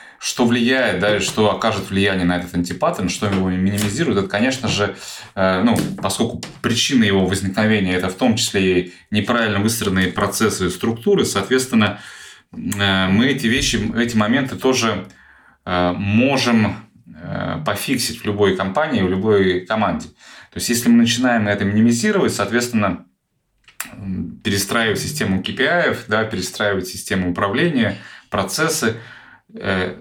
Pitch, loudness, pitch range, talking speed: 105 Hz, -18 LUFS, 95-115 Hz, 120 wpm